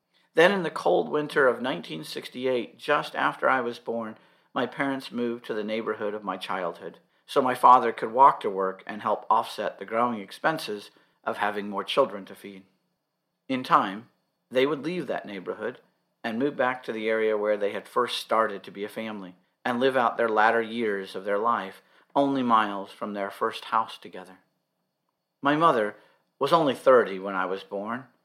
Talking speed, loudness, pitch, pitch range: 185 wpm, -26 LUFS, 110 Hz, 100-120 Hz